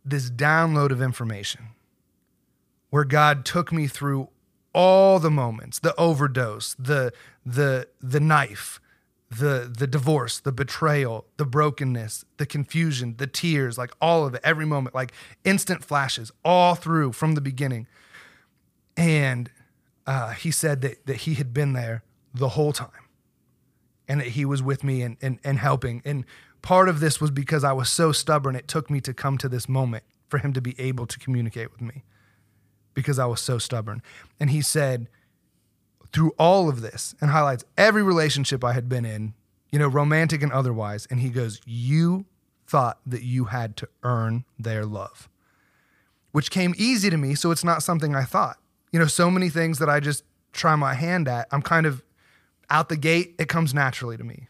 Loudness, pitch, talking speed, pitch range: -23 LUFS, 135 Hz, 180 wpm, 120-155 Hz